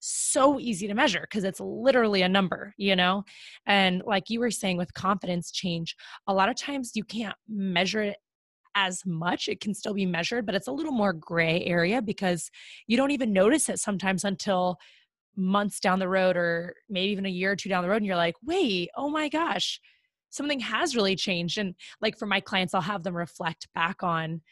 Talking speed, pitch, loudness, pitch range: 210 wpm, 195 Hz, -27 LUFS, 180-220 Hz